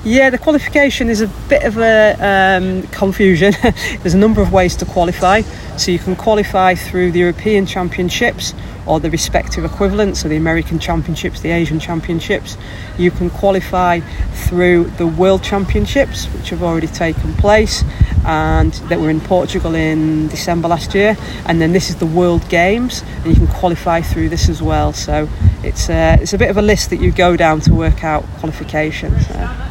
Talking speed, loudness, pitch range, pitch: 180 wpm, -14 LUFS, 160-195 Hz, 175 Hz